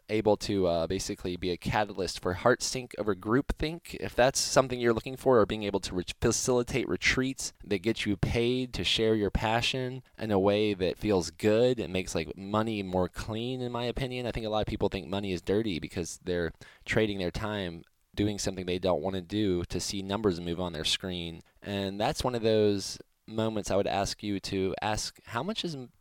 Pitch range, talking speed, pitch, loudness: 95-115 Hz, 215 wpm, 105 Hz, -30 LUFS